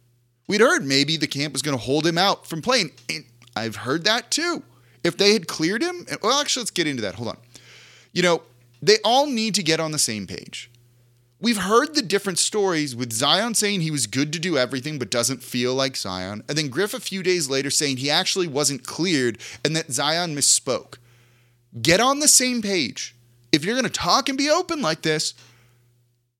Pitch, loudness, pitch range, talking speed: 150 Hz, -21 LUFS, 120-200 Hz, 210 wpm